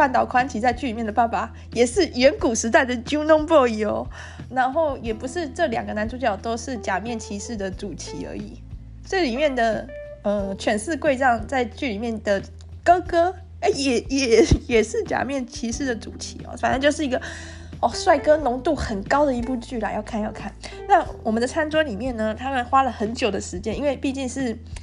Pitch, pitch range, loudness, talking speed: 250 Hz, 225-295 Hz, -22 LUFS, 295 characters per minute